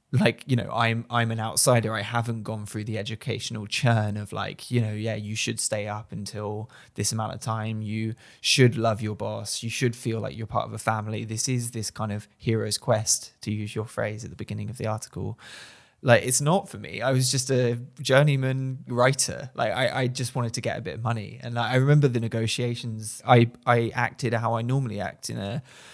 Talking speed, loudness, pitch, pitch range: 225 wpm, -26 LUFS, 115 Hz, 110-125 Hz